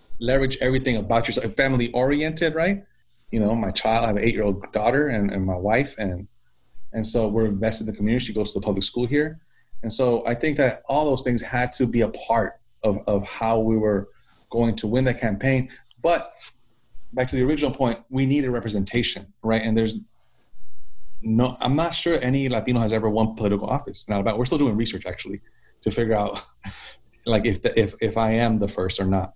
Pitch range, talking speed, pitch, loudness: 110-130 Hz, 215 wpm, 115 Hz, -22 LUFS